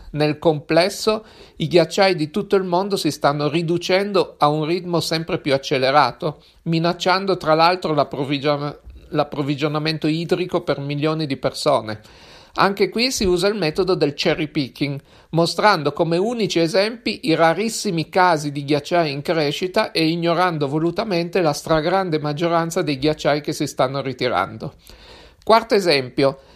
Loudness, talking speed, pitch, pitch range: -19 LUFS, 140 wpm, 165 Hz, 150-185 Hz